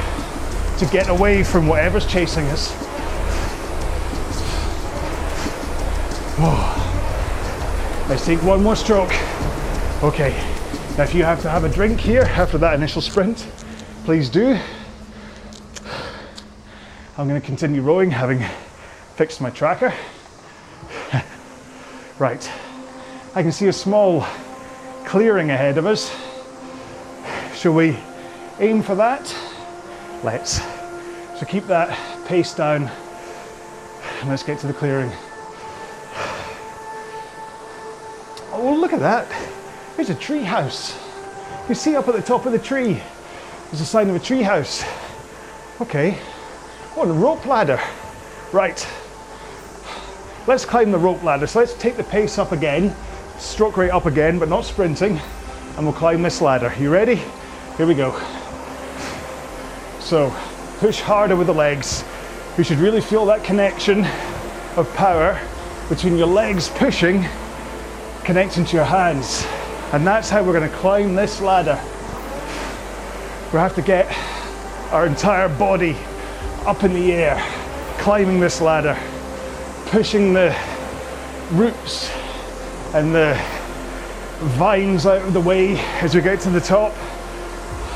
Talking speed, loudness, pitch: 130 wpm, -19 LUFS, 170 Hz